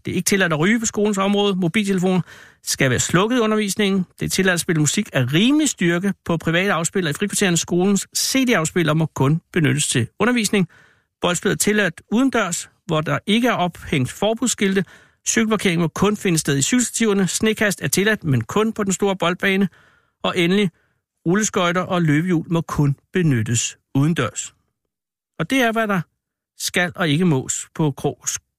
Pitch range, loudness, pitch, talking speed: 160-210 Hz, -19 LUFS, 185 Hz, 175 wpm